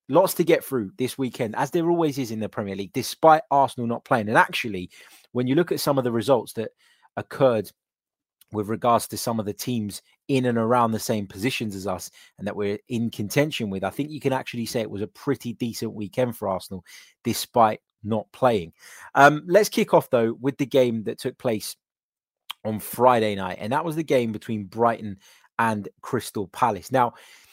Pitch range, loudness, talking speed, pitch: 105-140 Hz, -24 LUFS, 205 wpm, 120 Hz